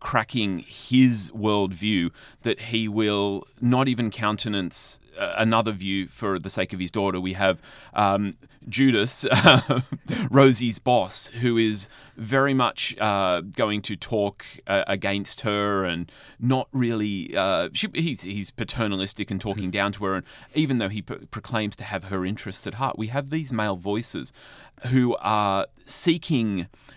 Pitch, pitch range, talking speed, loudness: 105 Hz, 100-125 Hz, 150 wpm, -24 LUFS